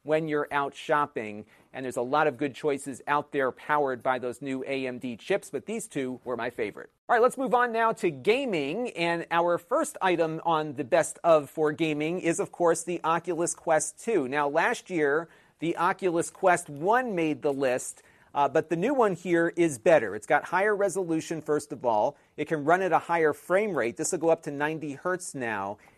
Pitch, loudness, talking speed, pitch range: 160 Hz, -27 LUFS, 210 wpm, 145-175 Hz